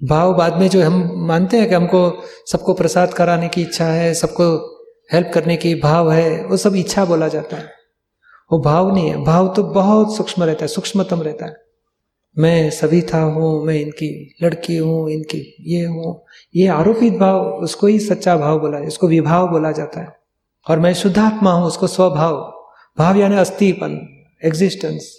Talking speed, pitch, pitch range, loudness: 175 wpm, 170 Hz, 160-185 Hz, -16 LUFS